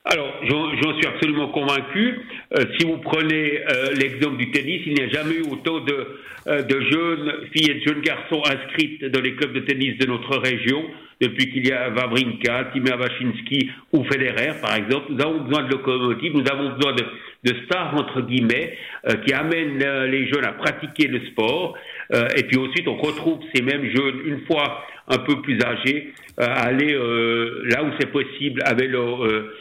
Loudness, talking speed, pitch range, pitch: -21 LUFS, 195 wpm, 130-150 Hz, 140 Hz